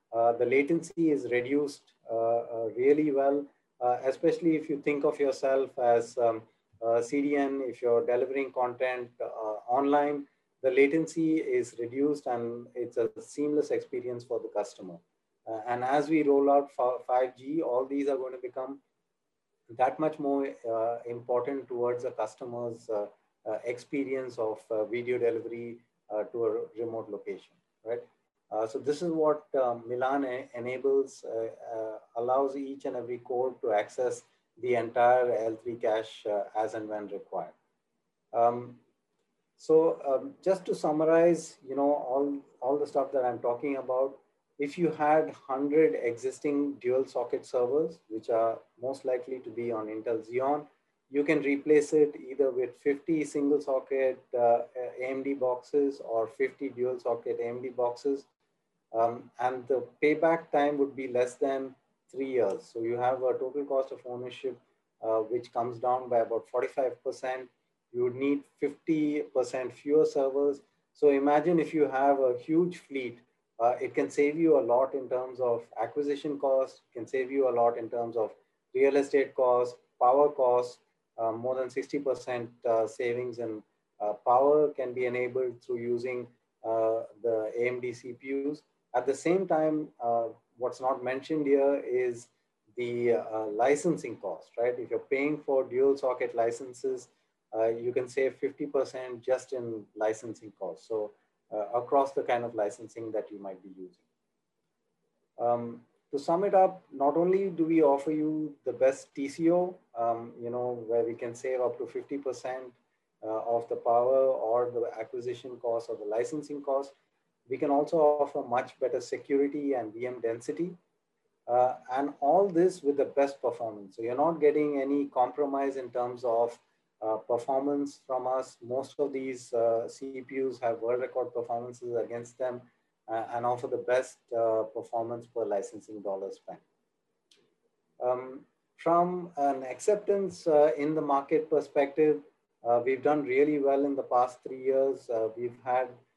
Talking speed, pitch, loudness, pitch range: 160 wpm, 130 Hz, -30 LUFS, 120-145 Hz